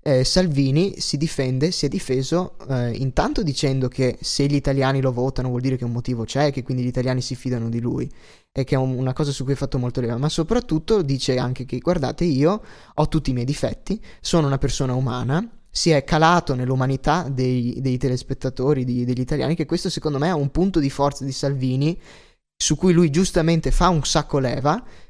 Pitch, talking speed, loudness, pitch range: 140 Hz, 210 wpm, -22 LUFS, 130-160 Hz